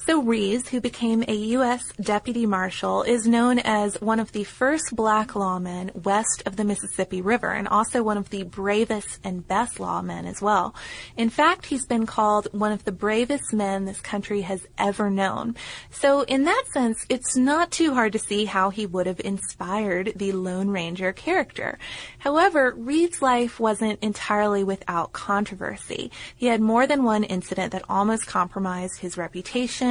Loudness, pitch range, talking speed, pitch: -24 LUFS, 195-240 Hz, 170 wpm, 215 Hz